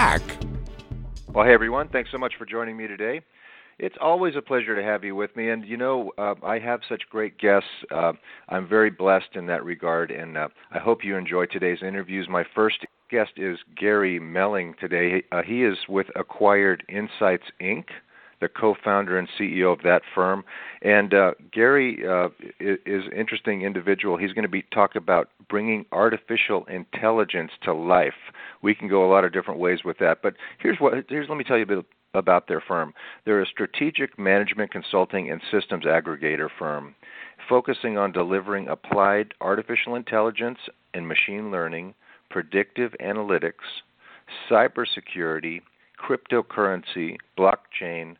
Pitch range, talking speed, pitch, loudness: 90-110 Hz, 160 wpm, 100 Hz, -24 LUFS